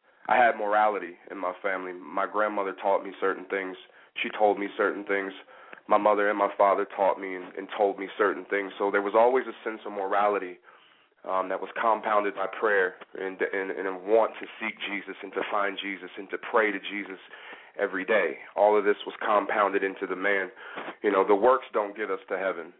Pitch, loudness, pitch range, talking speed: 100 Hz, -27 LUFS, 95-105 Hz, 210 wpm